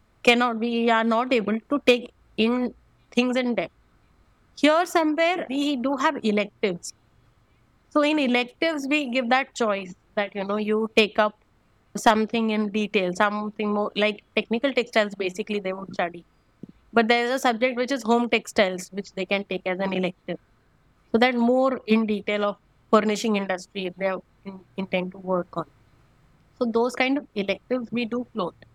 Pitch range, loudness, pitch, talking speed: 195-245 Hz, -24 LUFS, 215 Hz, 165 wpm